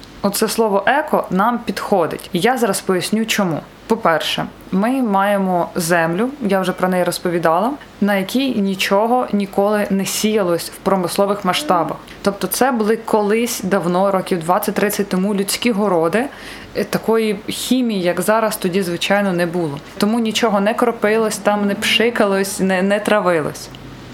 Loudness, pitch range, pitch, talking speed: -17 LUFS, 185-220 Hz, 200 Hz, 140 wpm